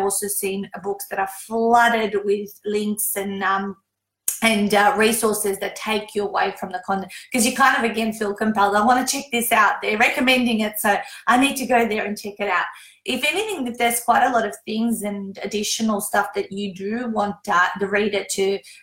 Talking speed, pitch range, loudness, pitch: 210 wpm, 200-230 Hz, -21 LUFS, 210 Hz